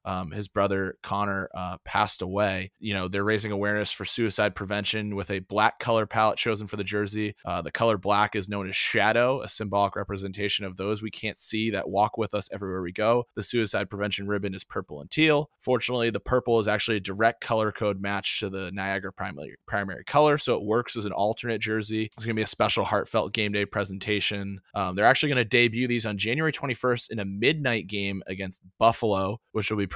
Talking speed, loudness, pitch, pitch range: 215 wpm, -26 LUFS, 105 Hz, 100-115 Hz